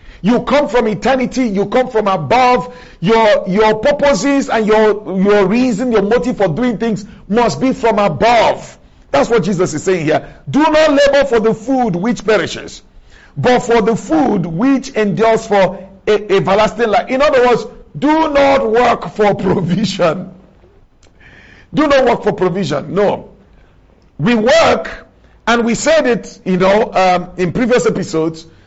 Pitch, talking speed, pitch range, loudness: 225 Hz, 155 wpm, 195-250 Hz, -13 LUFS